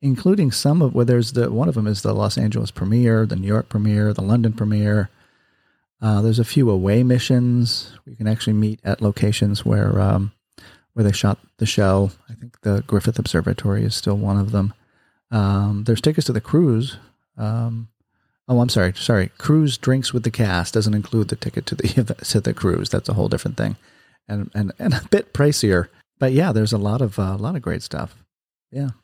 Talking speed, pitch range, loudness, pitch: 205 wpm, 105-120 Hz, -20 LUFS, 110 Hz